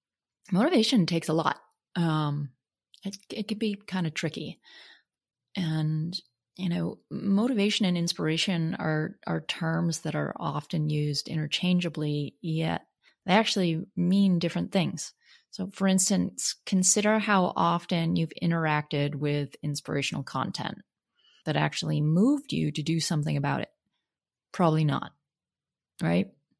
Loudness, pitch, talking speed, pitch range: -28 LUFS, 170 Hz, 125 wpm, 155-195 Hz